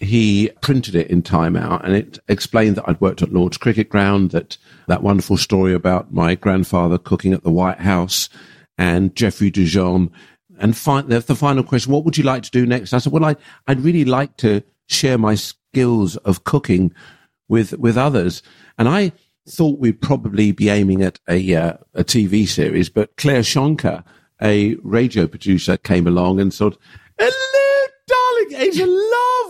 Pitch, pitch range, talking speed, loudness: 105 Hz, 95-140 Hz, 180 wpm, -17 LUFS